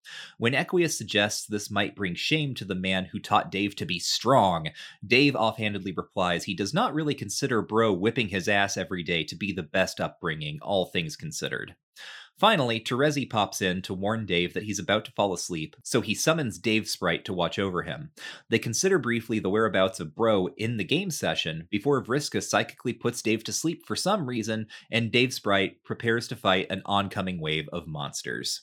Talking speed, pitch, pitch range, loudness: 195 wpm, 110 Hz, 95-120 Hz, -27 LUFS